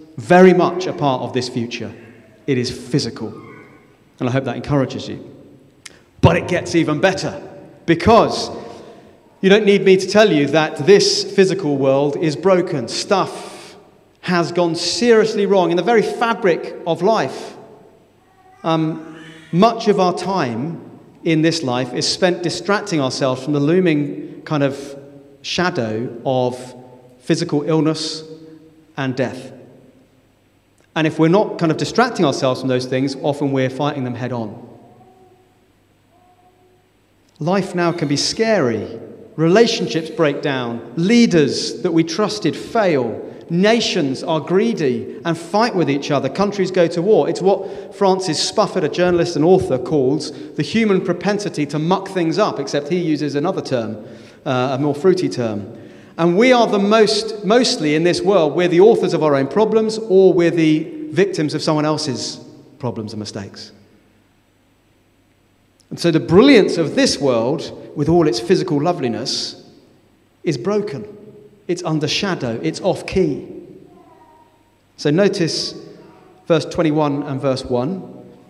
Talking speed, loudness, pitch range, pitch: 145 wpm, -17 LUFS, 130-185 Hz, 155 Hz